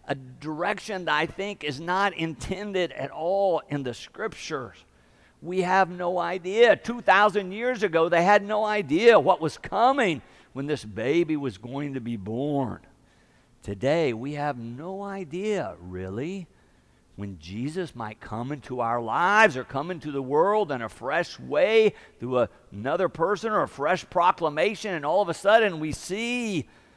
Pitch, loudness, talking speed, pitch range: 165 Hz, -25 LUFS, 160 wpm, 130-200 Hz